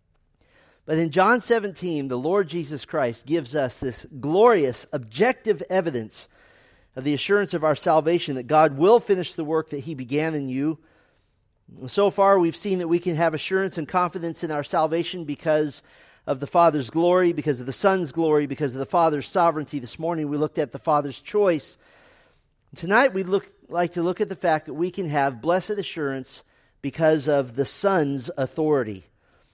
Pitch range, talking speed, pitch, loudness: 140-180 Hz, 180 wpm, 160 Hz, -23 LUFS